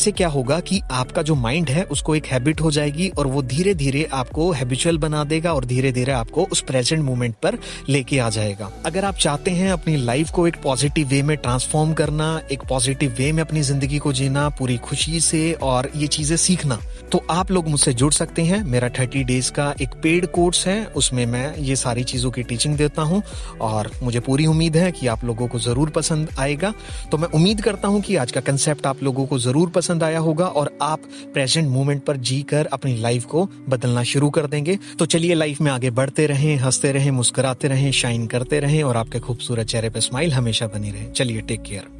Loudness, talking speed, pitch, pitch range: -20 LUFS, 200 wpm, 145 Hz, 130-160 Hz